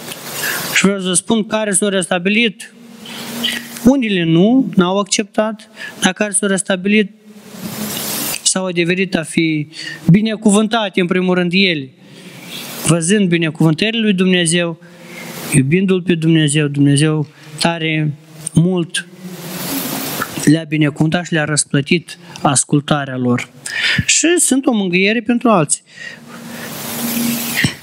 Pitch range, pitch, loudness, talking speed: 165-215 Hz, 185 Hz, -15 LUFS, 105 wpm